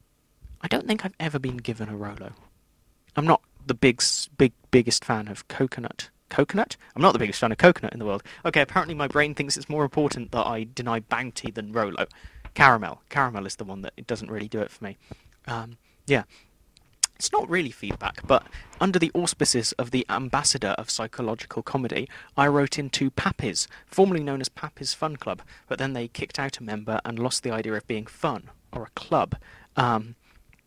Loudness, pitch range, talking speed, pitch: -25 LUFS, 110-145 Hz, 195 wpm, 125 Hz